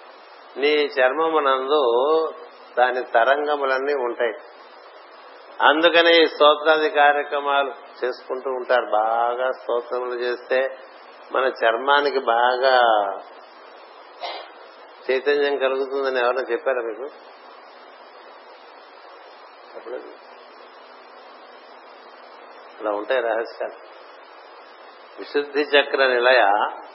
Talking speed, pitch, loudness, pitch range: 60 wpm, 130 Hz, -20 LUFS, 125-145 Hz